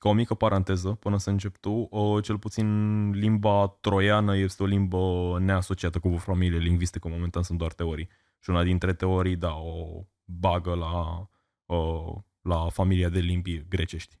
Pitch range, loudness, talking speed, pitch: 85-100 Hz, -27 LUFS, 155 wpm, 95 Hz